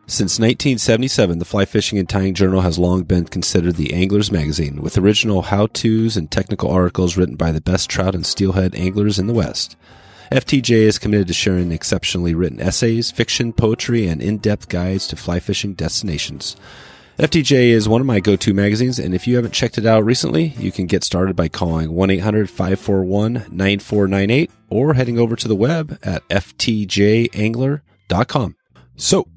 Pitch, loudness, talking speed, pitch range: 100 Hz, -17 LUFS, 175 wpm, 90-115 Hz